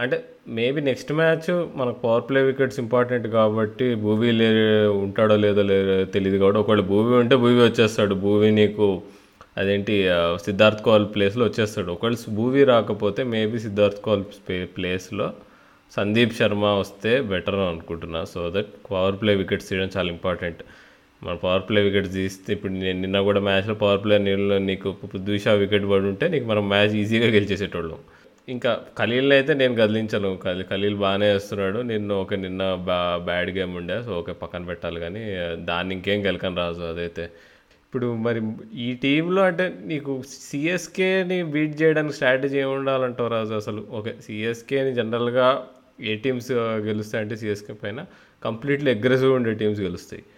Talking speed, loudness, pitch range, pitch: 150 wpm, -22 LUFS, 95-120 Hz, 105 Hz